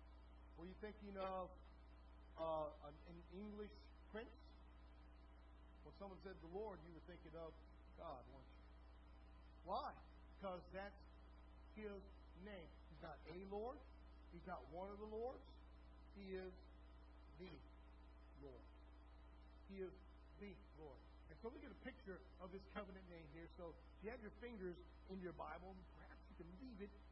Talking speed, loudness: 155 wpm, -57 LUFS